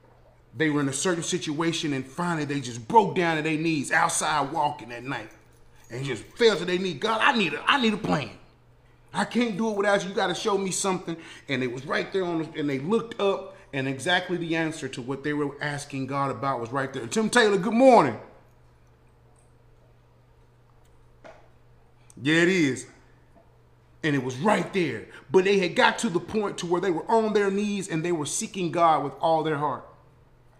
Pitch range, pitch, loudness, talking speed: 140-195 Hz, 165 Hz, -25 LUFS, 205 wpm